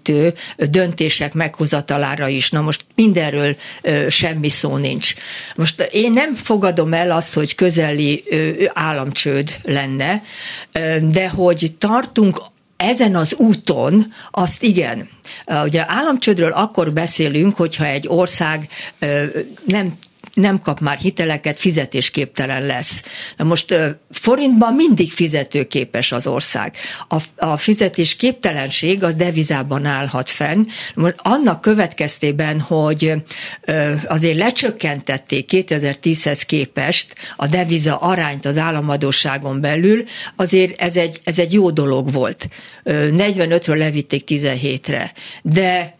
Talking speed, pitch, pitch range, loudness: 105 wpm, 165 Hz, 150-185 Hz, -17 LUFS